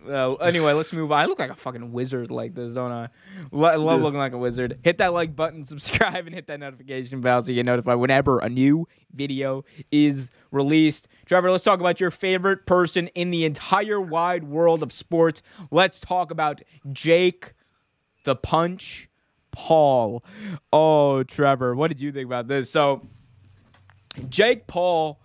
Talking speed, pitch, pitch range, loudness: 175 wpm, 150 Hz, 130-170 Hz, -22 LUFS